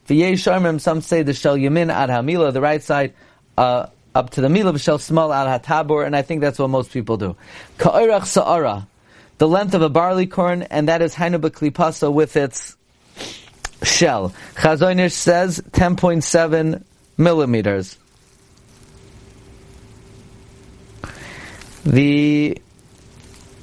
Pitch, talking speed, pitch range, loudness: 155 Hz, 130 wpm, 135-170 Hz, -18 LUFS